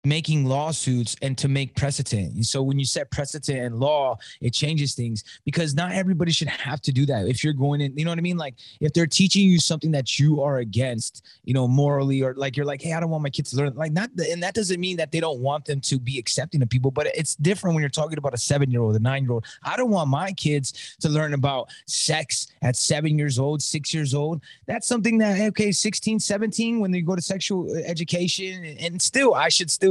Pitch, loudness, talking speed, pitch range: 150 Hz, -23 LUFS, 250 wpm, 135-170 Hz